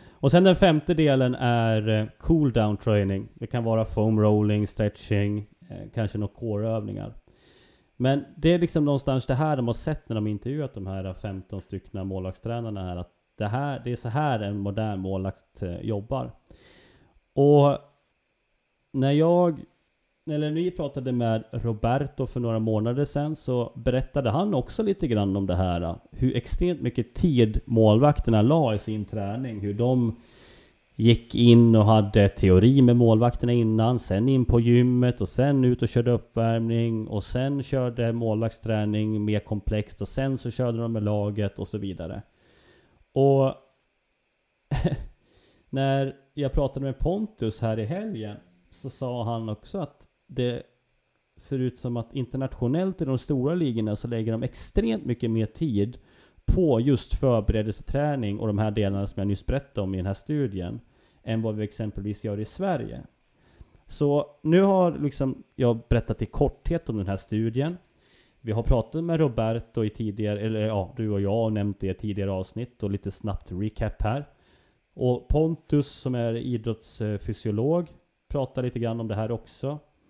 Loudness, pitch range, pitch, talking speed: -25 LUFS, 105-135 Hz, 115 Hz, 165 wpm